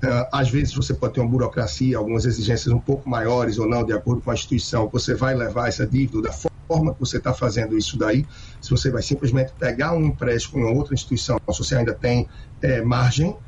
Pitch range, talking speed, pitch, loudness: 115-130 Hz, 215 wpm, 125 Hz, -22 LUFS